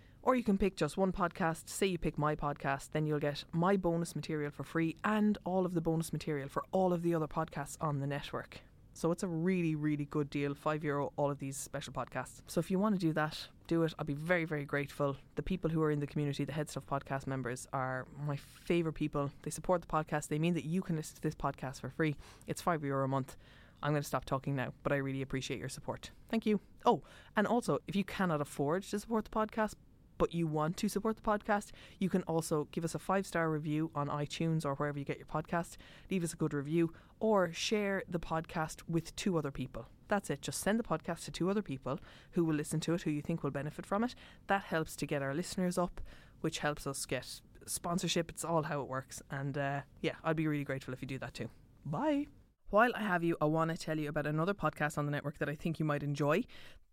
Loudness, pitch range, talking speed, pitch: -36 LUFS, 140-175 Hz, 245 wpm, 155 Hz